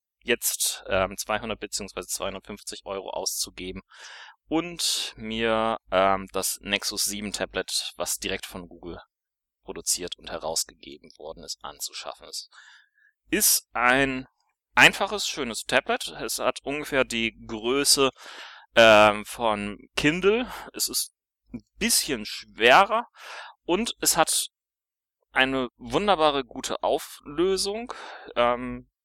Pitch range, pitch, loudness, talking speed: 100-135 Hz, 115 Hz, -24 LUFS, 105 wpm